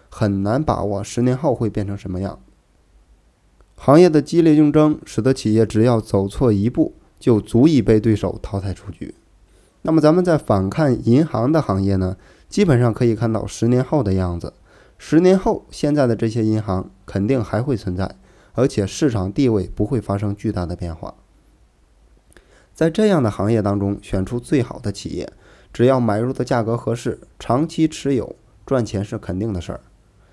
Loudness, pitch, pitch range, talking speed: -19 LUFS, 110 Hz, 100-130 Hz, 265 characters per minute